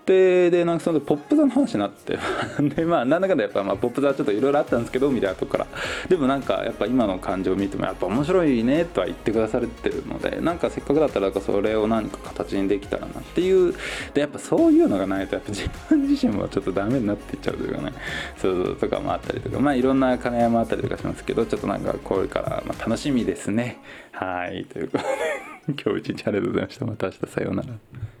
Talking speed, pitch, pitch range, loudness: 530 characters per minute, 135 Hz, 115-190 Hz, -23 LUFS